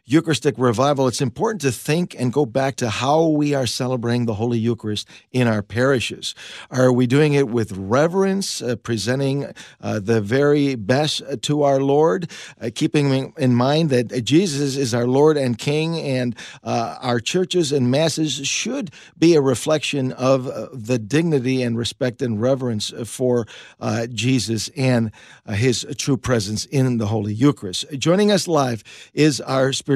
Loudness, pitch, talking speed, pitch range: -20 LUFS, 130 Hz, 160 wpm, 120-145 Hz